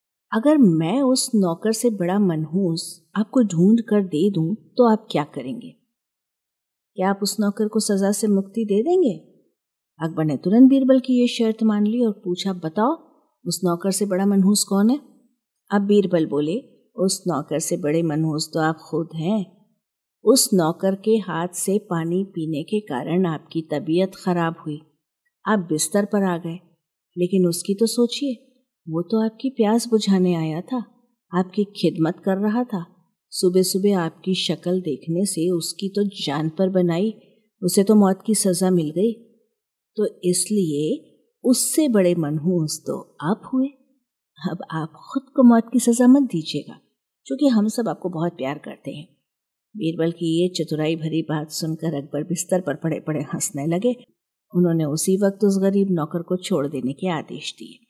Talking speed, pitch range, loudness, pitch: 165 wpm, 165-220 Hz, -21 LUFS, 190 Hz